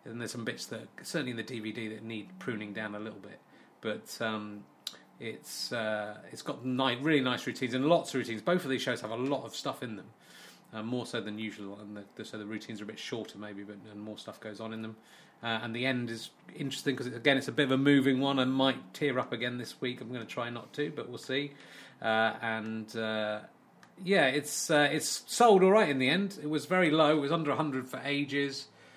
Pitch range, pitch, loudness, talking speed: 110-140 Hz, 125 Hz, -31 LUFS, 245 wpm